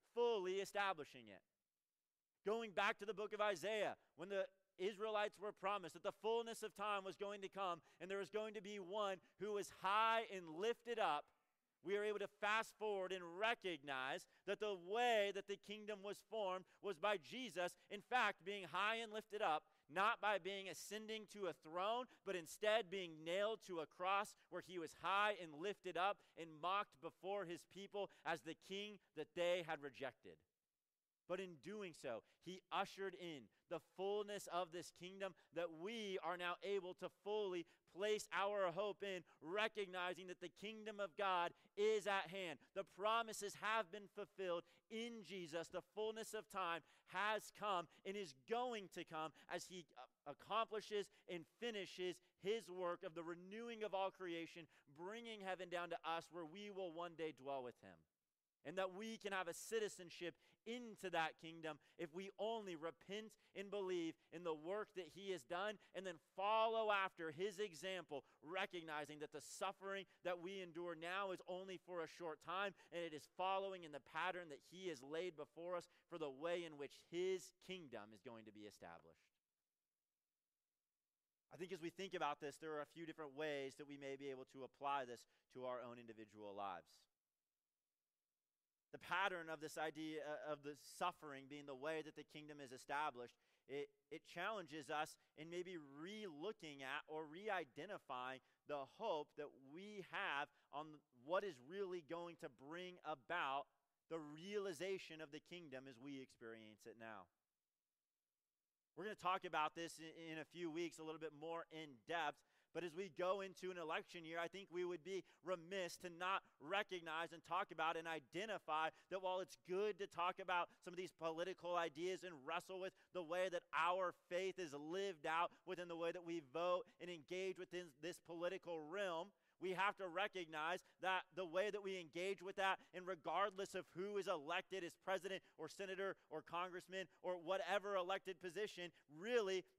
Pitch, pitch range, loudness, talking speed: 180 Hz, 155-195 Hz, -48 LUFS, 180 wpm